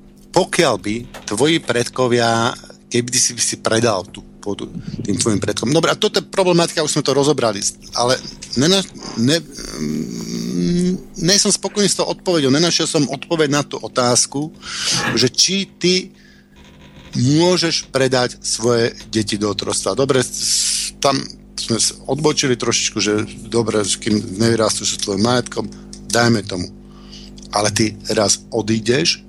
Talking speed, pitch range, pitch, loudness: 135 wpm, 110-155 Hz, 120 Hz, -17 LUFS